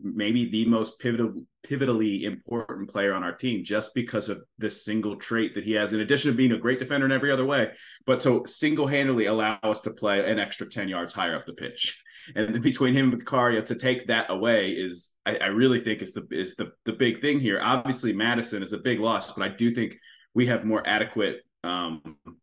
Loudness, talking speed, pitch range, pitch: -26 LUFS, 220 wpm, 105-125 Hz, 115 Hz